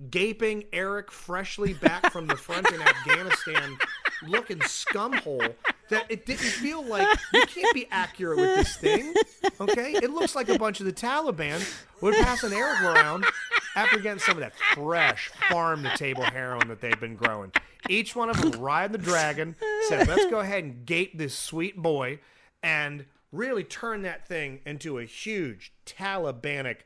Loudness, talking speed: -26 LUFS, 165 wpm